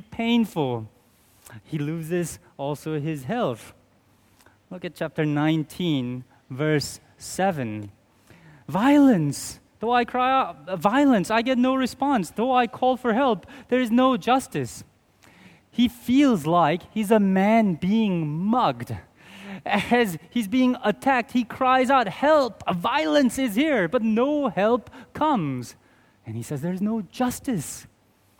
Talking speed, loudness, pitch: 130 wpm, -23 LUFS, 200 Hz